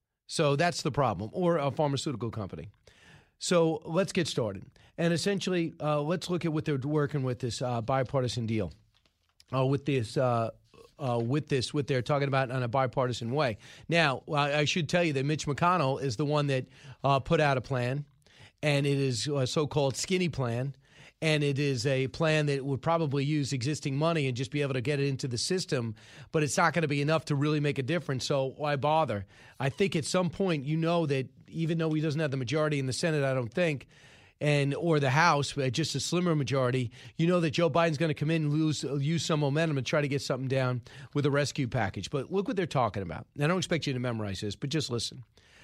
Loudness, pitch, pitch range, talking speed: -29 LUFS, 145 Hz, 130-160 Hz, 225 wpm